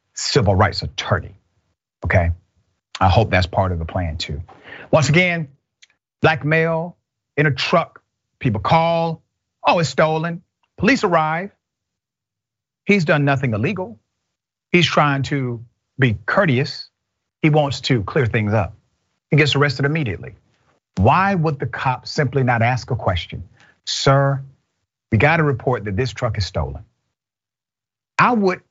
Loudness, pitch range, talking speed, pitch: -18 LUFS, 105-155 Hz, 140 wpm, 130 Hz